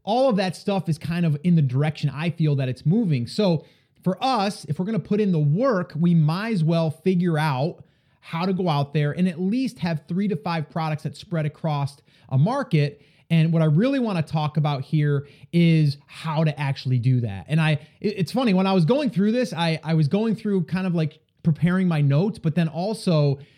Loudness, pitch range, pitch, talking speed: -23 LUFS, 150-185 Hz, 165 Hz, 225 wpm